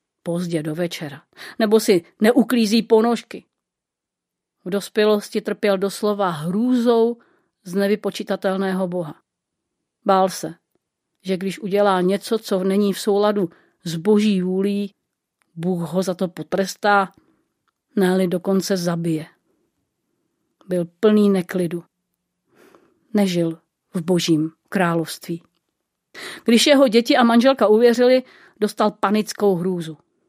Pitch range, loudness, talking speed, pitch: 180-215 Hz, -20 LUFS, 105 wpm, 195 Hz